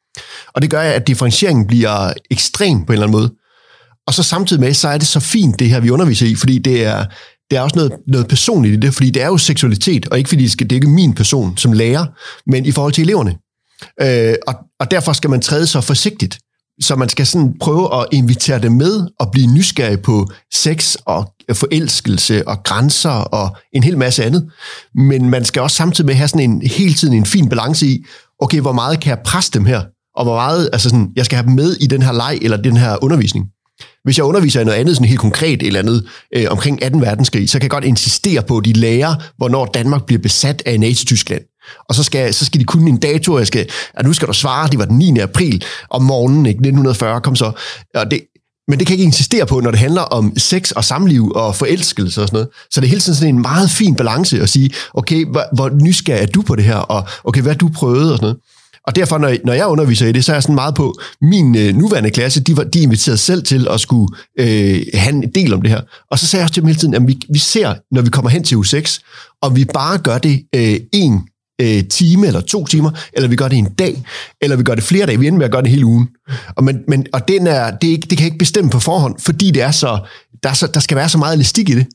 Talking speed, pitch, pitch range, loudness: 255 wpm, 135 Hz, 120-155 Hz, -13 LUFS